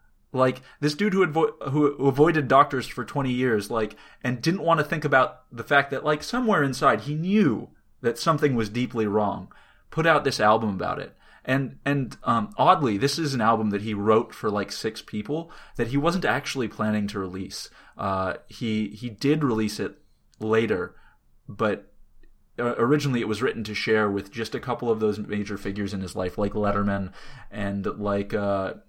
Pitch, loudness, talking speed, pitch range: 120 Hz, -25 LUFS, 185 wpm, 105-145 Hz